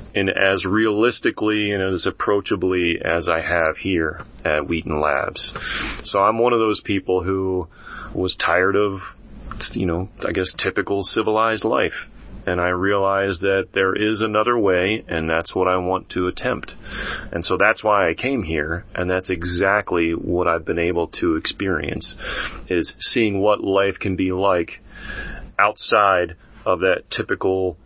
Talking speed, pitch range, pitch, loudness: 155 wpm, 90-105 Hz, 95 Hz, -20 LUFS